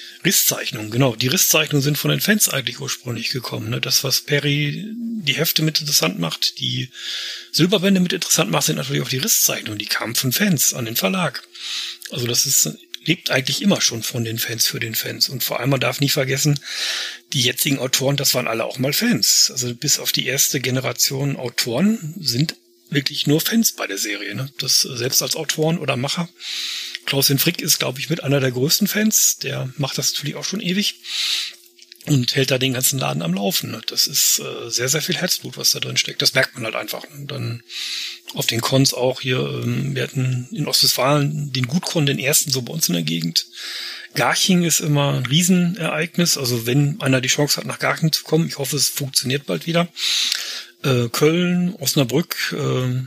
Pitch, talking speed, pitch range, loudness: 140 Hz, 195 wpm, 125-160 Hz, -19 LUFS